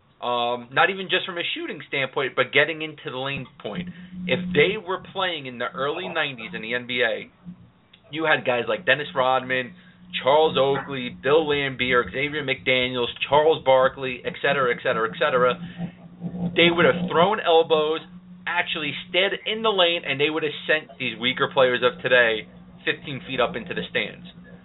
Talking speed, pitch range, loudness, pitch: 175 wpm, 130-175 Hz, -22 LUFS, 155 Hz